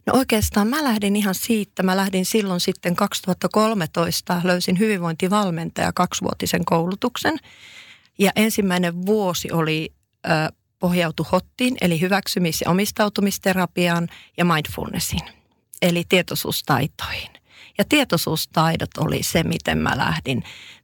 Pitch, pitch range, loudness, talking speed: 185 Hz, 170-205 Hz, -21 LUFS, 105 wpm